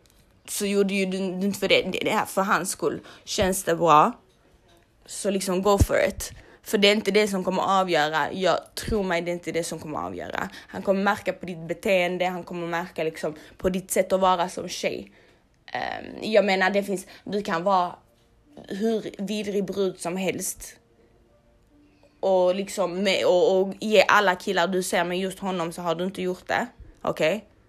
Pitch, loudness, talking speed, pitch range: 185 Hz, -24 LUFS, 190 wpm, 165-200 Hz